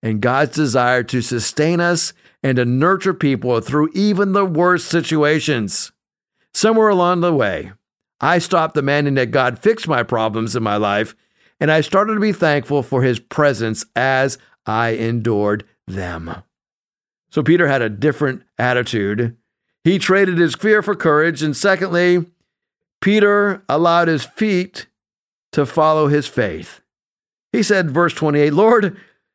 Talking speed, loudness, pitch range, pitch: 145 wpm, -17 LUFS, 125-180 Hz, 150 Hz